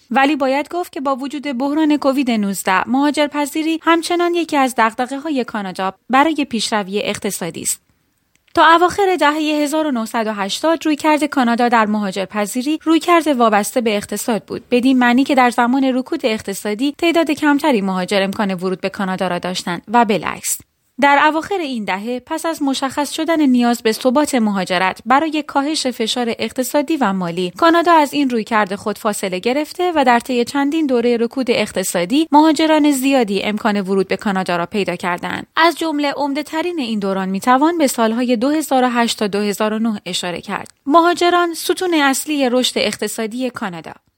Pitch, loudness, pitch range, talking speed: 255 Hz, -16 LUFS, 210-300 Hz, 160 wpm